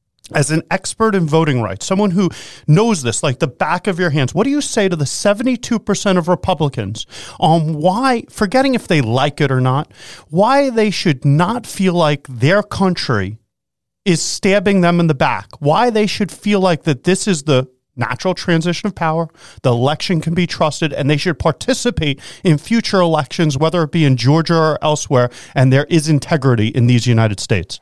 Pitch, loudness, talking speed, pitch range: 160 Hz, -15 LUFS, 190 wpm, 140-190 Hz